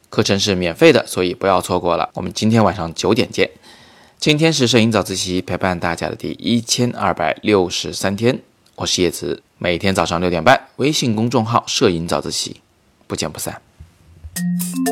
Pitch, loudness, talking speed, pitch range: 95 Hz, -17 LUFS, 280 characters per minute, 85-115 Hz